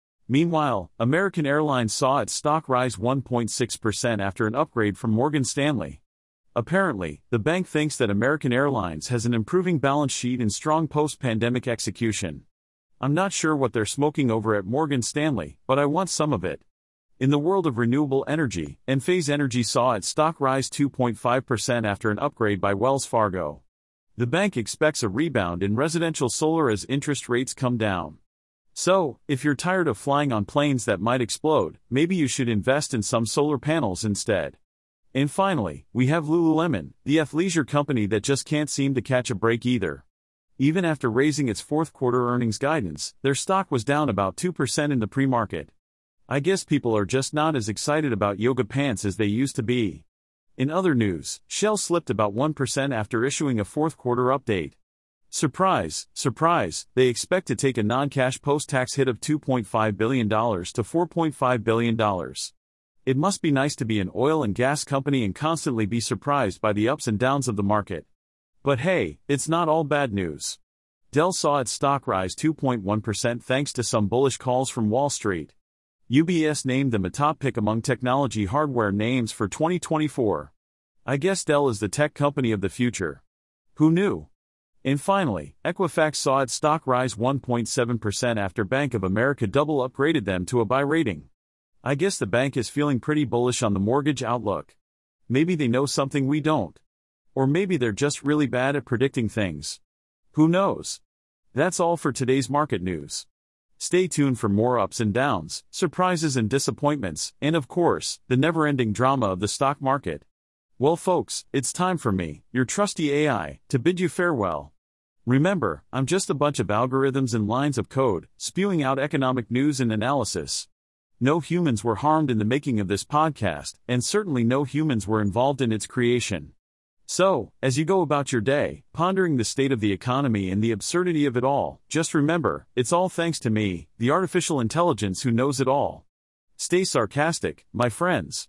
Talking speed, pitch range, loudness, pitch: 180 wpm, 110-150 Hz, -24 LUFS, 130 Hz